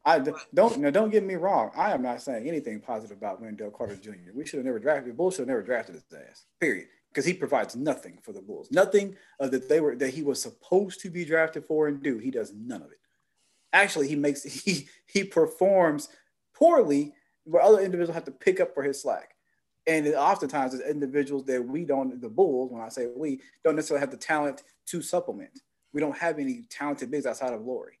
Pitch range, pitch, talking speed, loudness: 140-190 Hz, 155 Hz, 225 wpm, -27 LUFS